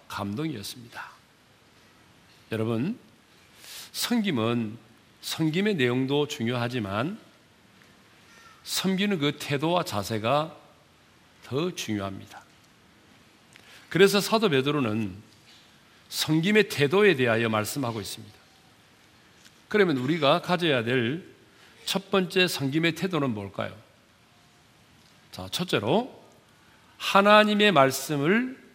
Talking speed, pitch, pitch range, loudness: 205 characters per minute, 135 Hz, 110-180 Hz, -25 LUFS